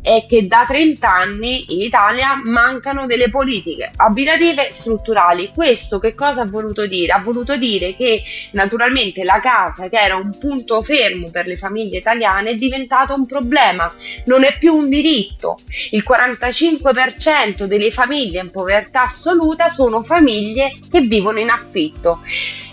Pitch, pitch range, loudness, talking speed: 240 Hz, 210-275 Hz, -14 LUFS, 150 wpm